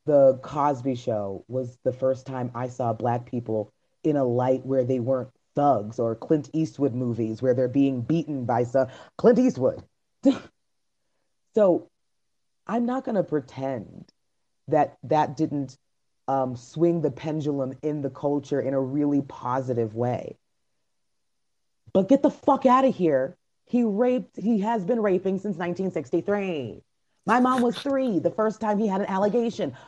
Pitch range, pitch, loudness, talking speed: 130-195 Hz, 145 Hz, -25 LUFS, 155 wpm